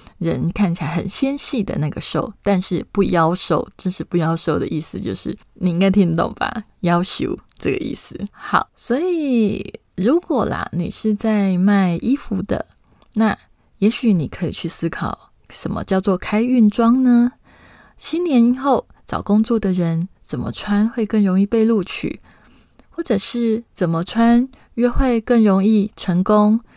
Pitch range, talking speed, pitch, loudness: 180-235 Hz, 225 characters per minute, 210 Hz, -19 LUFS